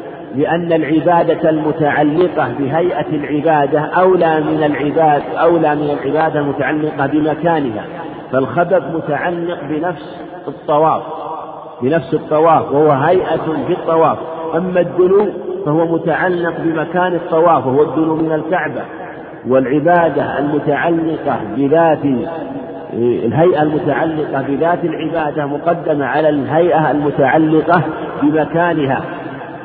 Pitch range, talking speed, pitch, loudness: 150-165 Hz, 90 wpm, 155 Hz, -15 LUFS